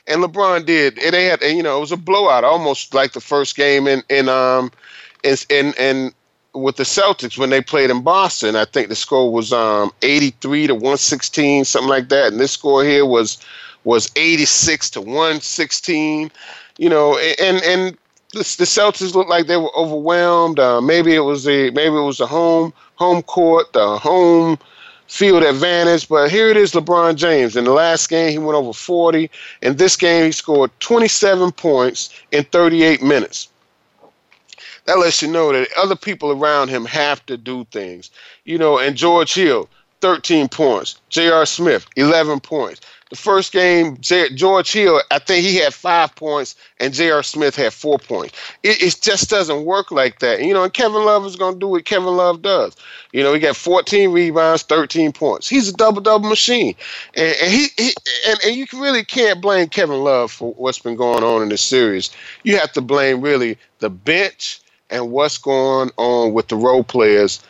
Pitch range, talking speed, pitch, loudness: 135-180 Hz, 190 wpm, 160 Hz, -15 LUFS